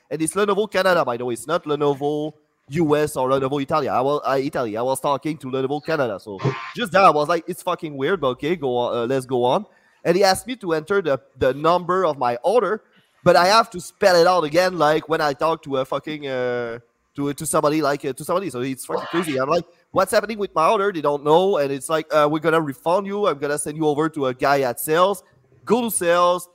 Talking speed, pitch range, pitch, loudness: 255 wpm, 135-175 Hz, 155 Hz, -20 LUFS